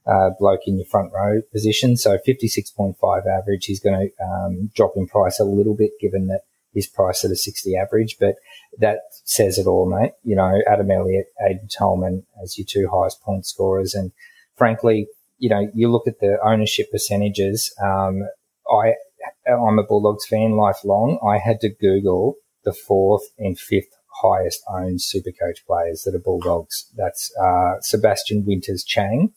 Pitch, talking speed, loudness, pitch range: 100 Hz, 170 wpm, -20 LUFS, 95-110 Hz